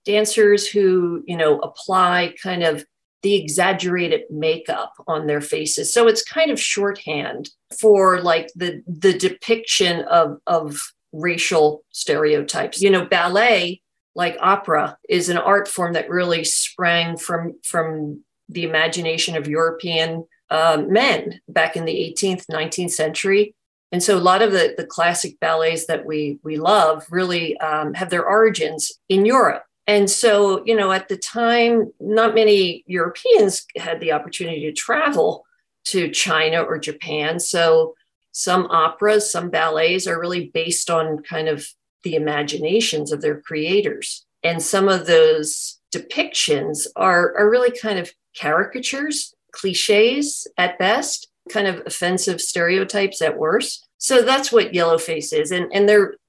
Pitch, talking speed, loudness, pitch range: 180 Hz, 145 wpm, -19 LUFS, 160-205 Hz